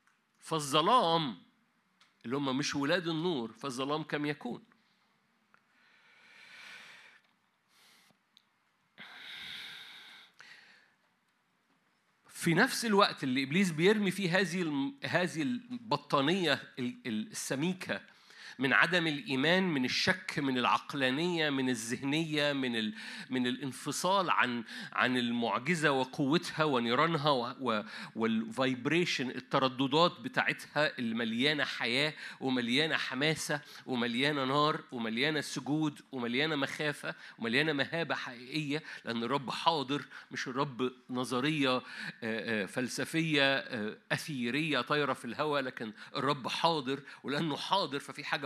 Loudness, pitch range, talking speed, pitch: -32 LUFS, 130-165 Hz, 90 wpm, 145 Hz